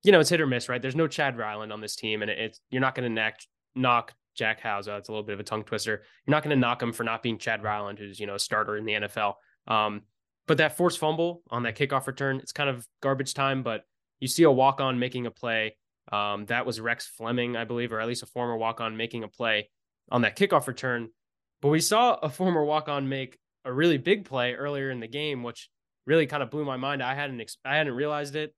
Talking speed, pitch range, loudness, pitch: 255 wpm, 110-145 Hz, -27 LUFS, 125 Hz